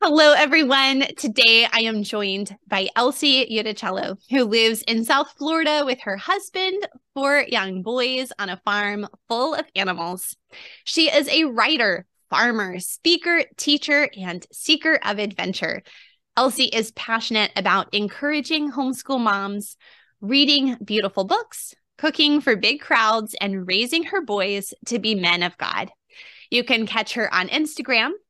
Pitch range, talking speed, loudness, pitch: 205-295 Hz, 140 wpm, -20 LUFS, 240 Hz